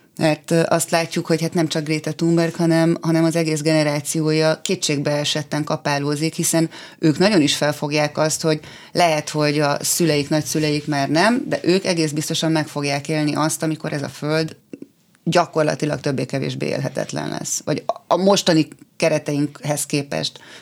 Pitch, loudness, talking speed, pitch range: 155 Hz, -20 LUFS, 150 wpm, 150-165 Hz